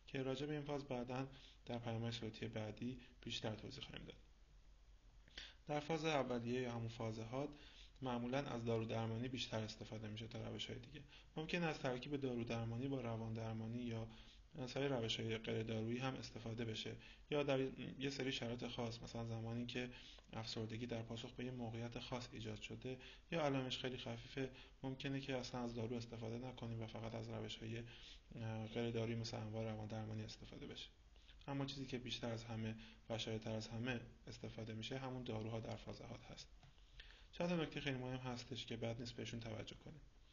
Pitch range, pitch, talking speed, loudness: 110-130 Hz, 115 Hz, 175 wpm, -47 LUFS